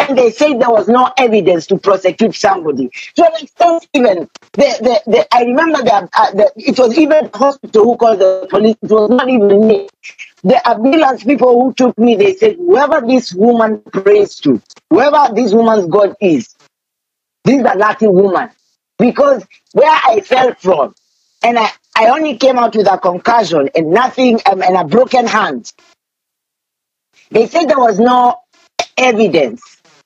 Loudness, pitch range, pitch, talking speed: -11 LUFS, 210-280 Hz, 240 Hz, 165 wpm